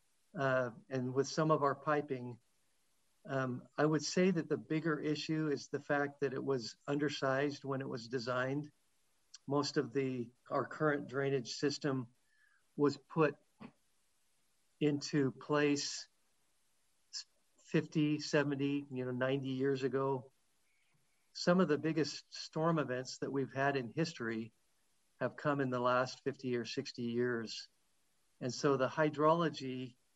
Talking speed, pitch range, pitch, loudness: 135 wpm, 130-150 Hz, 140 Hz, -36 LUFS